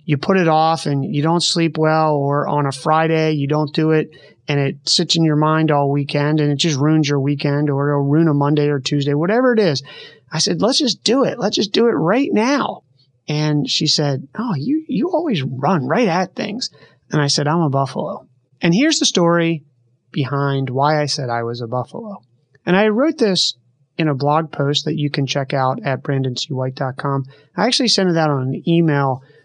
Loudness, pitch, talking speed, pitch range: -17 LUFS, 150 Hz, 215 wpm, 140-170 Hz